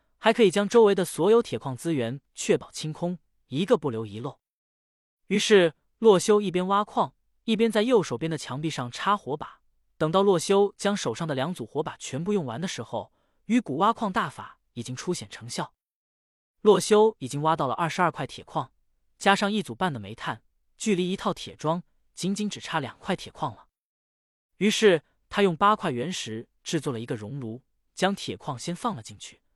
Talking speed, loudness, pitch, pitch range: 270 characters per minute, -26 LUFS, 170 Hz, 130-200 Hz